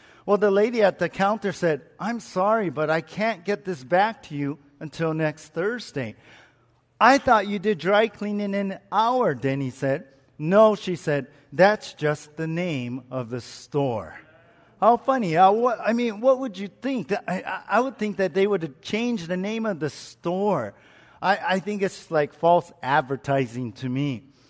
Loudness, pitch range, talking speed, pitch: -24 LUFS, 145-210 Hz, 170 wpm, 185 Hz